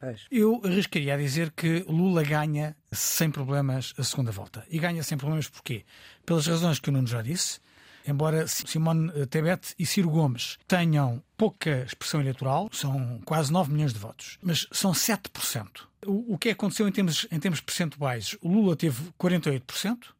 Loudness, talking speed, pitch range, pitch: -27 LUFS, 165 wpm, 140-180 Hz, 160 Hz